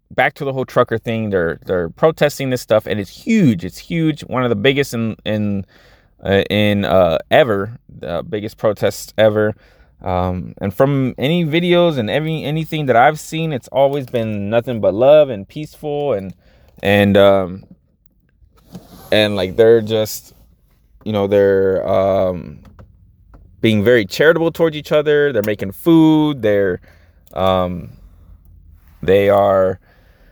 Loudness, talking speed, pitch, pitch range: -16 LUFS, 145 wpm, 105 Hz, 95-140 Hz